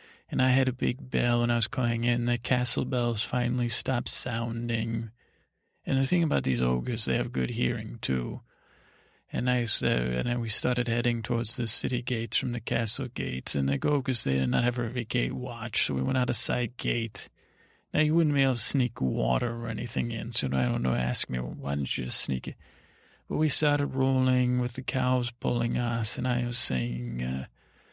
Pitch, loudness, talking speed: 120 Hz, -28 LUFS, 215 wpm